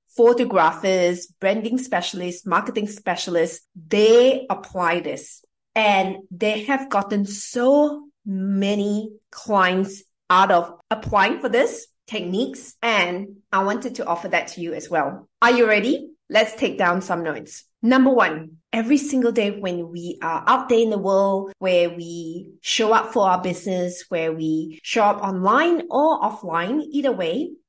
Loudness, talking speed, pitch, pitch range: -21 LUFS, 145 wpm, 200 Hz, 180-240 Hz